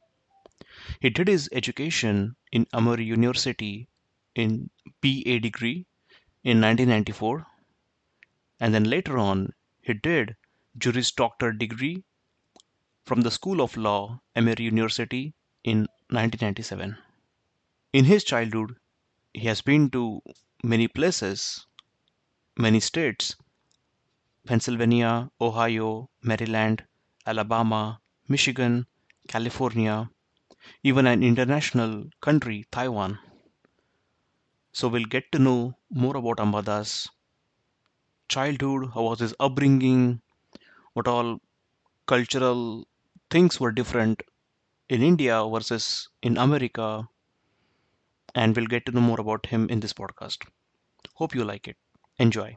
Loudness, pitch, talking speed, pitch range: -25 LUFS, 120 Hz, 105 wpm, 110-130 Hz